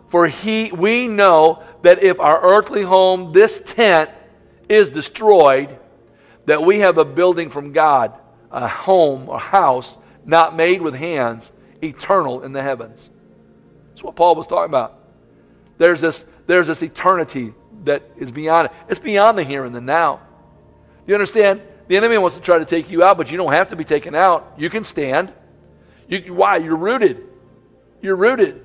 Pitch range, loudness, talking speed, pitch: 150-200 Hz, -15 LUFS, 170 wpm, 170 Hz